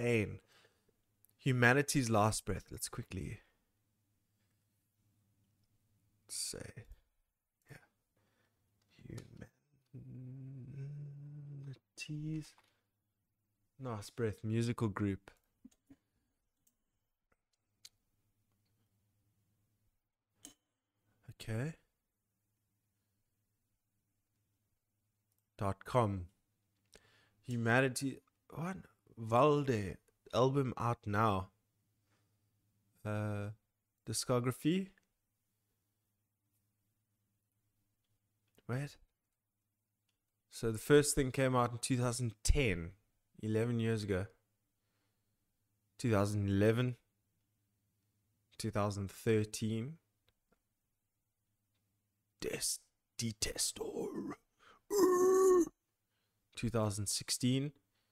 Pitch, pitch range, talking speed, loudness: 105 Hz, 105-120 Hz, 45 wpm, -36 LUFS